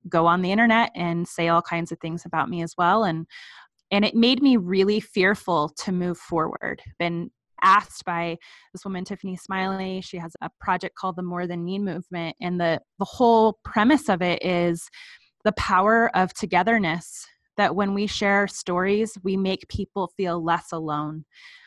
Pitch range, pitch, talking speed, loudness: 170-200 Hz, 185 Hz, 175 wpm, -23 LUFS